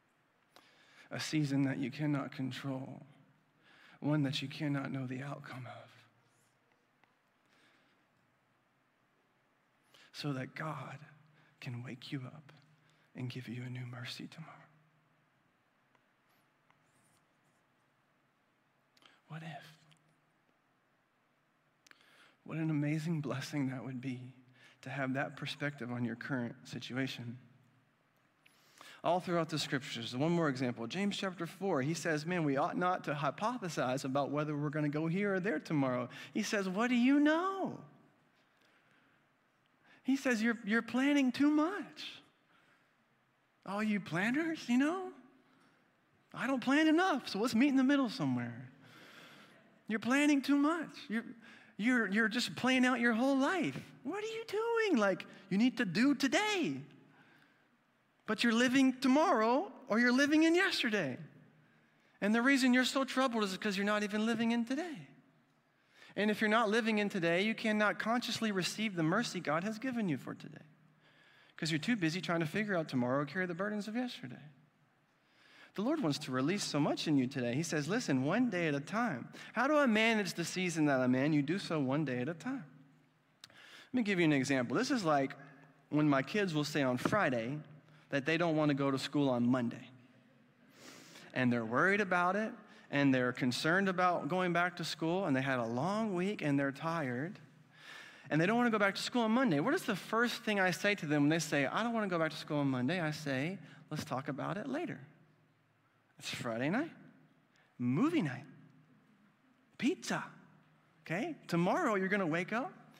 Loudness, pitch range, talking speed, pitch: -34 LUFS, 140-225 Hz, 170 wpm, 165 Hz